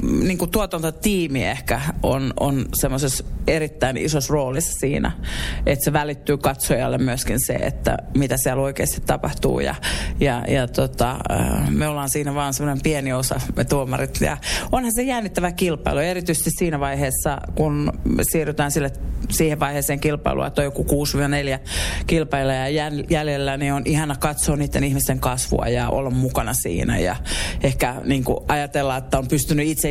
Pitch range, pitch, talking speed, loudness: 130-155 Hz, 140 Hz, 150 wpm, -21 LUFS